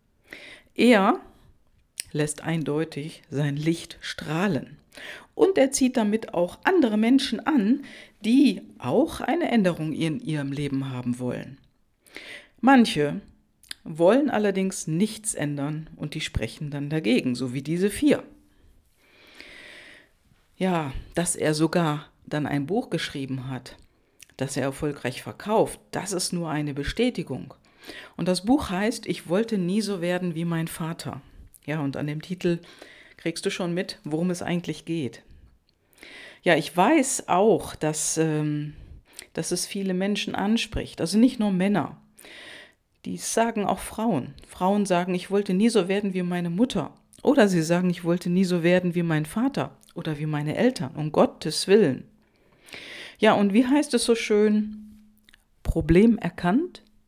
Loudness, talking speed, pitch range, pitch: -25 LUFS, 145 wpm, 150-215 Hz, 175 Hz